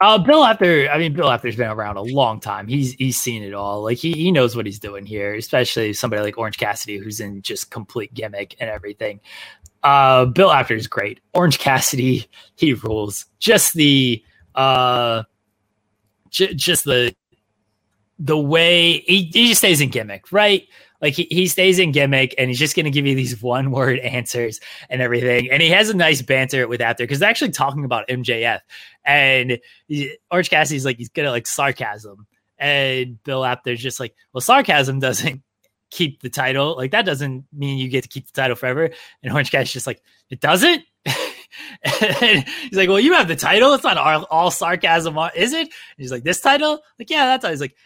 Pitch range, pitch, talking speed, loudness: 120-165 Hz, 130 Hz, 190 wpm, -17 LUFS